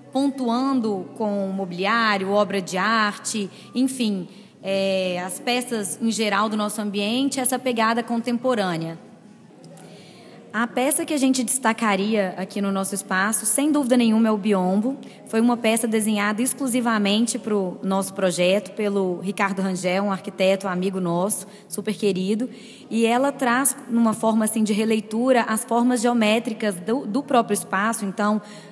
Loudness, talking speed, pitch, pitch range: -21 LUFS, 145 wpm, 215 Hz, 200-235 Hz